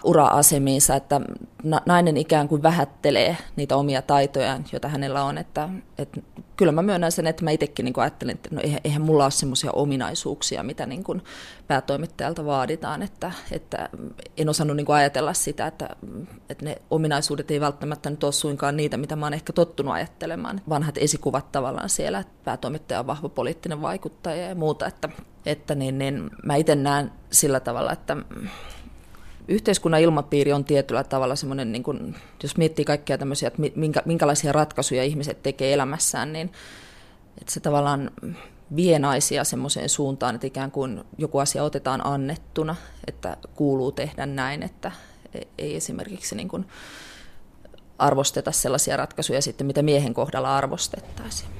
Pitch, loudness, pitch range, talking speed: 145 Hz, -24 LUFS, 135-155 Hz, 150 wpm